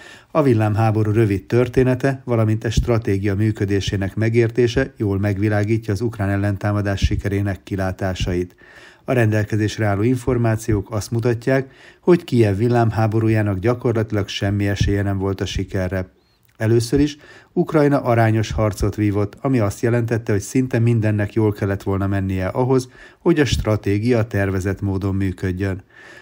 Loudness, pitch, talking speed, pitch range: -20 LUFS, 110 Hz, 125 wpm, 100-120 Hz